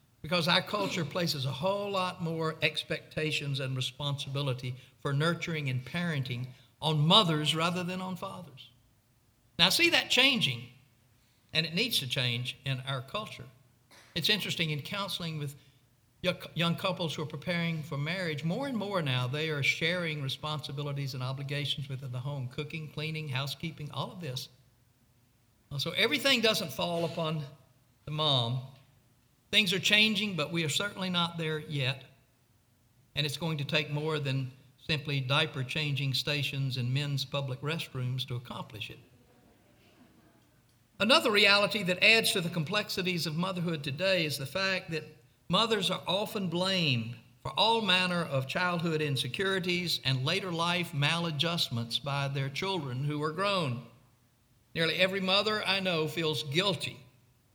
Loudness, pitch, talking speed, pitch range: -30 LUFS, 150 Hz, 145 wpm, 130-175 Hz